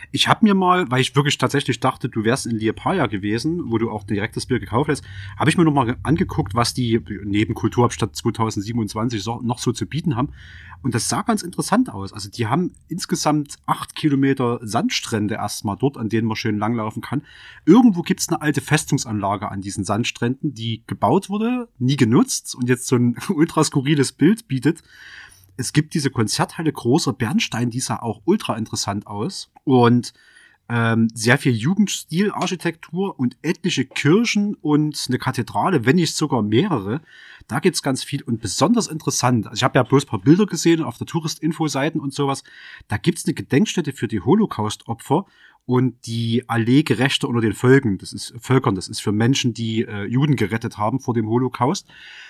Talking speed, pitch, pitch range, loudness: 180 wpm, 130 Hz, 115-155 Hz, -20 LUFS